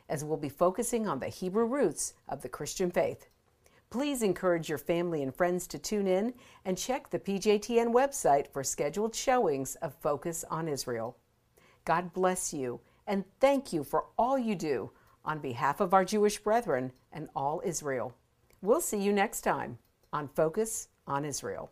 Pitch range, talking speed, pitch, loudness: 145-215 Hz, 170 wpm, 180 Hz, -31 LUFS